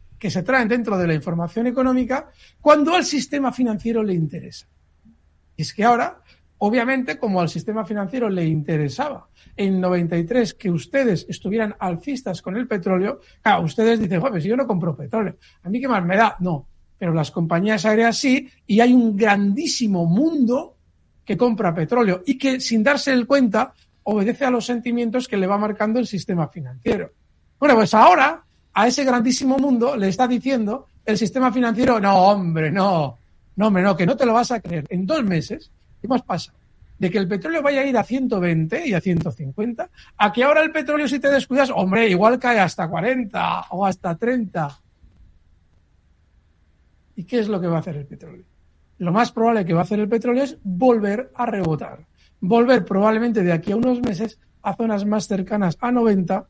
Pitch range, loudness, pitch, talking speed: 175-245 Hz, -20 LUFS, 210 Hz, 185 wpm